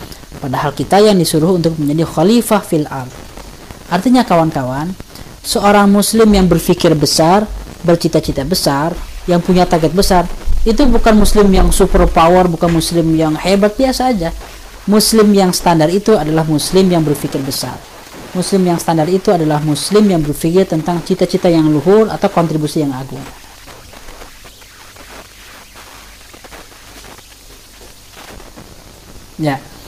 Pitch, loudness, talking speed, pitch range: 170 Hz, -12 LUFS, 120 wpm, 150-195 Hz